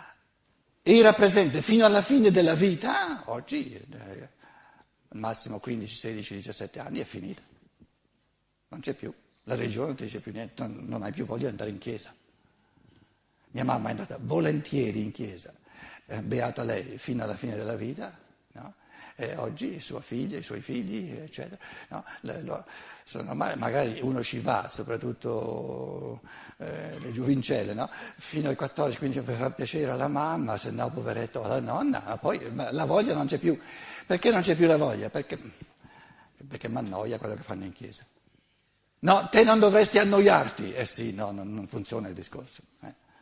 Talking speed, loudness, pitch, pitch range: 160 wpm, -27 LUFS, 130 Hz, 110-175 Hz